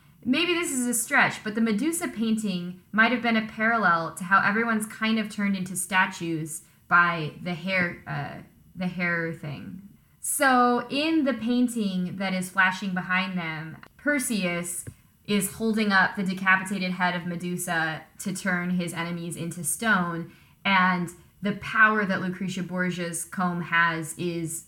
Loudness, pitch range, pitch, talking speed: -25 LUFS, 175-220 Hz, 185 Hz, 150 wpm